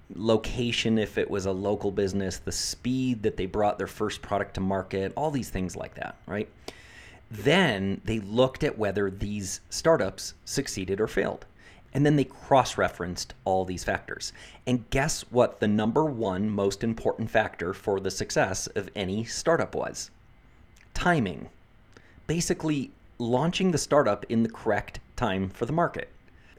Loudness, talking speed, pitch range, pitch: -28 LUFS, 155 wpm, 95-125 Hz, 105 Hz